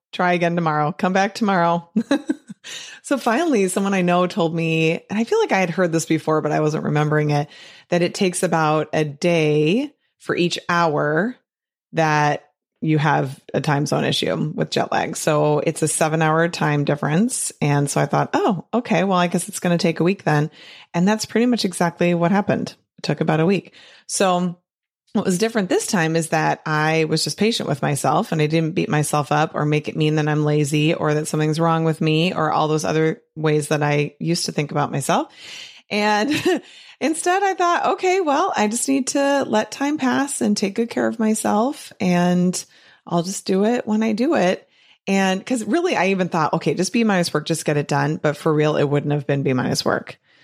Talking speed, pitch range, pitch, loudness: 215 wpm, 155-215 Hz, 175 Hz, -20 LUFS